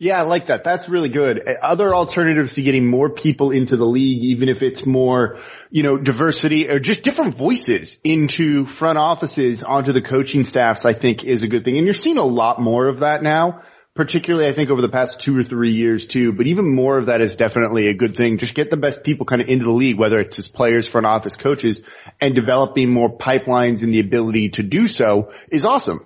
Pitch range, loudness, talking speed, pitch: 120-150 Hz, -17 LUFS, 230 wpm, 130 Hz